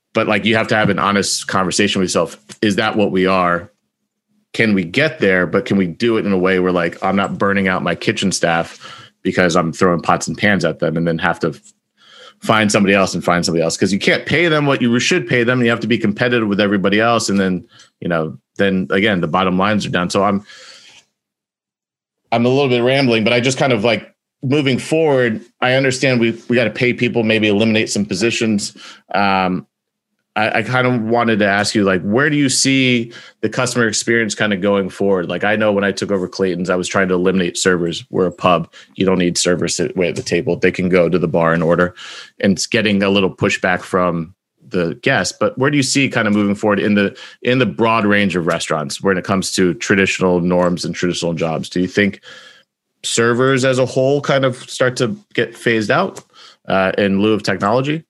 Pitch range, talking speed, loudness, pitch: 90-120 Hz, 225 wpm, -16 LUFS, 100 Hz